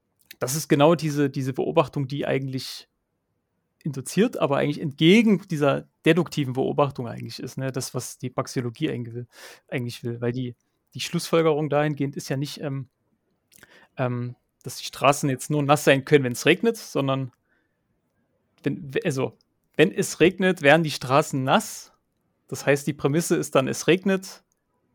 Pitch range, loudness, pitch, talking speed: 130-160 Hz, -23 LUFS, 145 Hz, 155 wpm